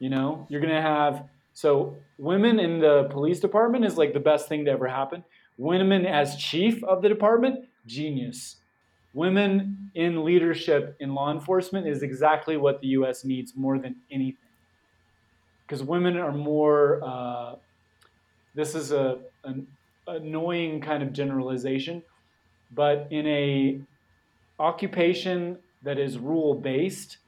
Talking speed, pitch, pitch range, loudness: 135 wpm, 145 Hz, 135-170 Hz, -25 LUFS